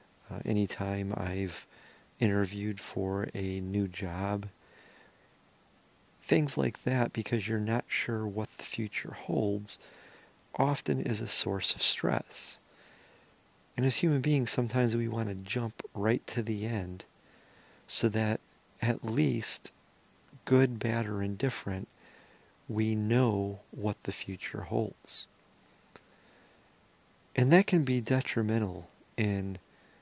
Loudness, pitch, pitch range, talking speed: -31 LUFS, 110 Hz, 100-120 Hz, 115 wpm